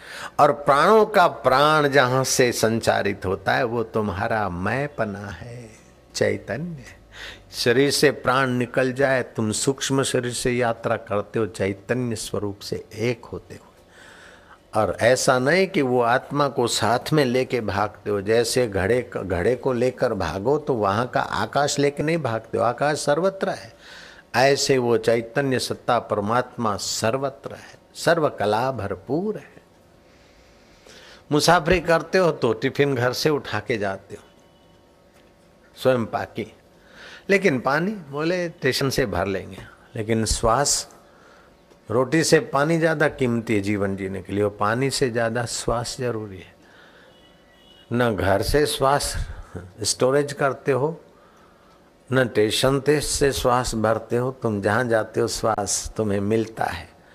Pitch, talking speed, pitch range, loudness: 120 Hz, 140 wpm, 105-140 Hz, -22 LUFS